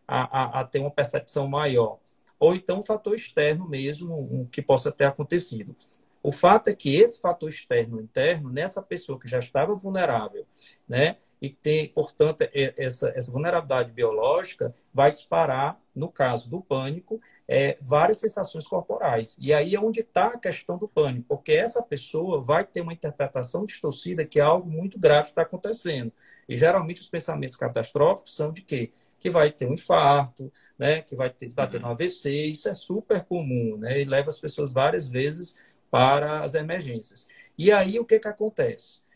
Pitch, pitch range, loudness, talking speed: 150 Hz, 135-185 Hz, -25 LUFS, 175 wpm